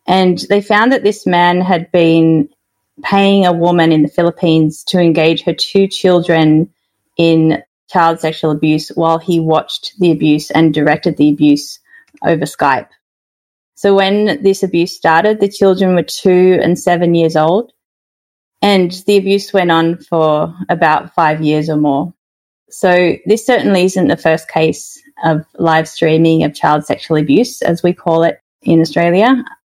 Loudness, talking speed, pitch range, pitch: -12 LUFS, 160 wpm, 160-195 Hz, 170 Hz